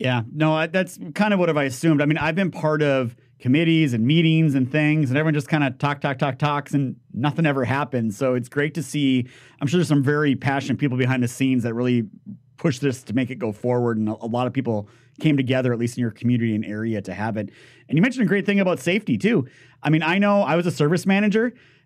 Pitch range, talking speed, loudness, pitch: 125-160 Hz, 260 wpm, -22 LUFS, 140 Hz